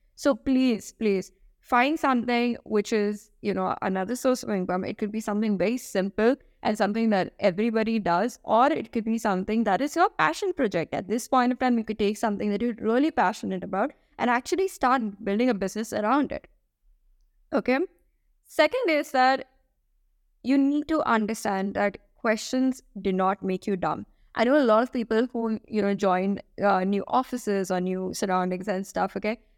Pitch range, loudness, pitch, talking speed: 200-255 Hz, -26 LUFS, 220 Hz, 185 wpm